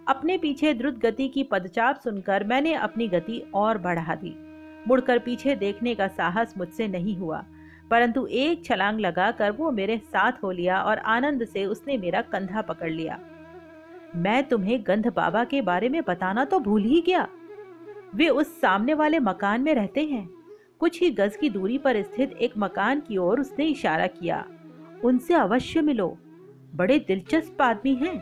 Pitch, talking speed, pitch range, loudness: 240 Hz, 170 wpm, 195-295 Hz, -25 LUFS